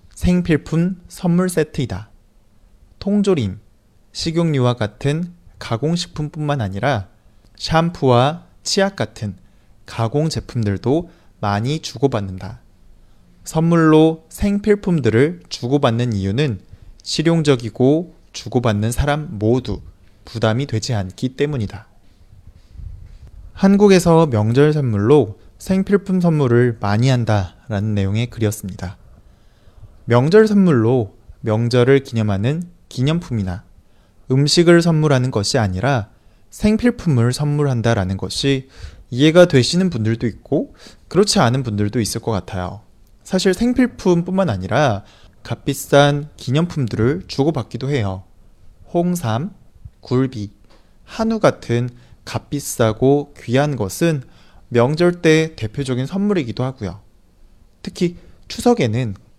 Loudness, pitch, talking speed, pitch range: -18 LUFS, 120 Hz, 245 characters per minute, 105-155 Hz